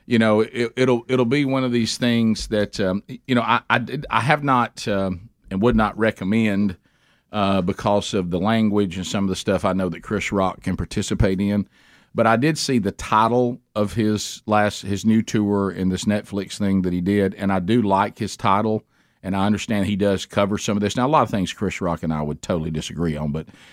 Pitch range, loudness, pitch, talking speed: 95-115 Hz, -21 LUFS, 105 Hz, 230 wpm